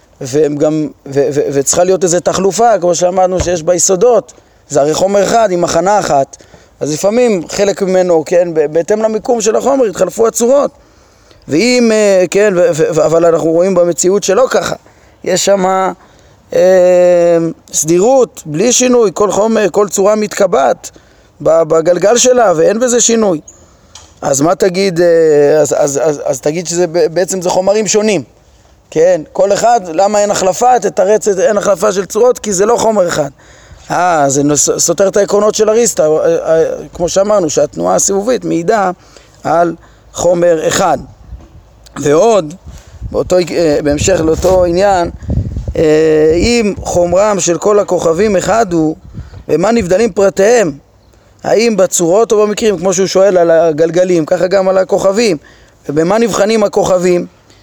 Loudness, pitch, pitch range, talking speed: -11 LUFS, 185 Hz, 165-210 Hz, 145 wpm